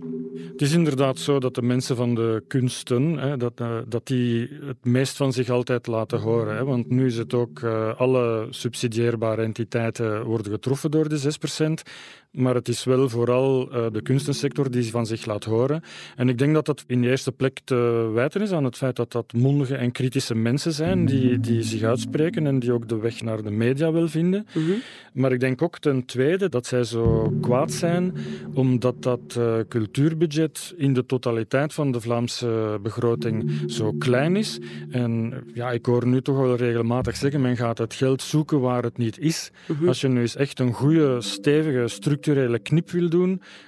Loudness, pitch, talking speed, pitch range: -23 LUFS, 125 Hz, 185 wpm, 115-140 Hz